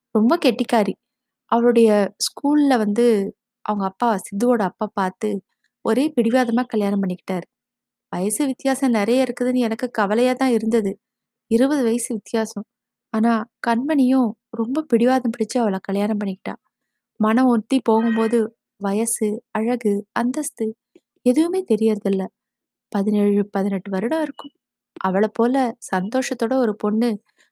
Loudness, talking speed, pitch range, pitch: -20 LUFS, 110 wpm, 210-250 Hz, 230 Hz